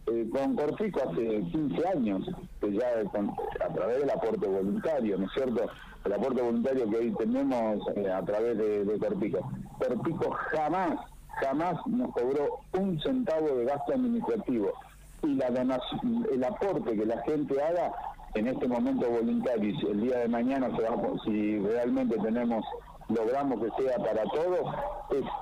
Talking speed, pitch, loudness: 160 wpm, 135 Hz, -30 LUFS